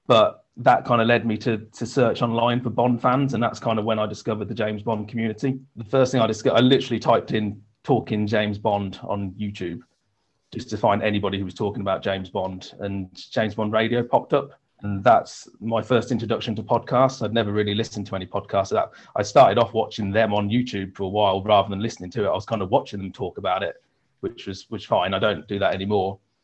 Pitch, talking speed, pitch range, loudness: 110 Hz, 230 wpm, 100-120 Hz, -23 LUFS